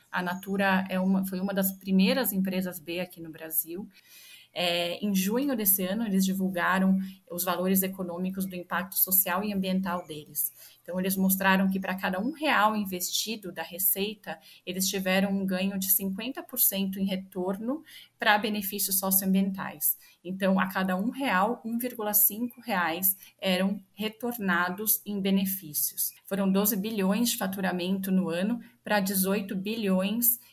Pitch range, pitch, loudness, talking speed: 185-205 Hz, 190 Hz, -27 LUFS, 140 wpm